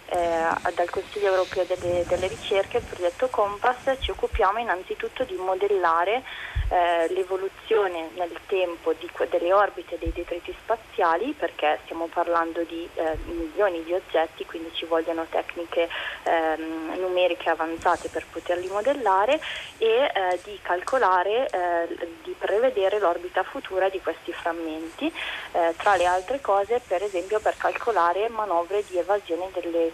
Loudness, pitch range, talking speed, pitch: -25 LUFS, 170-205 Hz, 135 wpm, 180 Hz